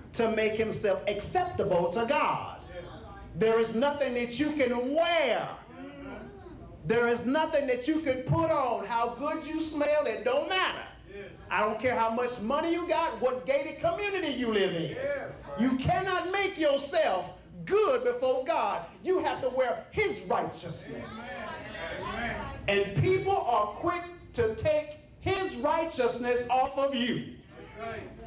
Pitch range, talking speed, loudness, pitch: 240-335 Hz, 140 wpm, -29 LUFS, 285 Hz